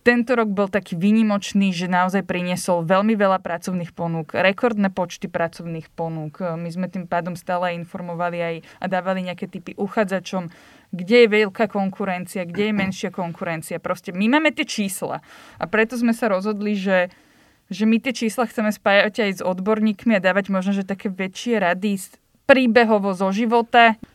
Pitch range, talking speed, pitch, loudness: 180-215 Hz, 160 wpm, 195 Hz, -21 LUFS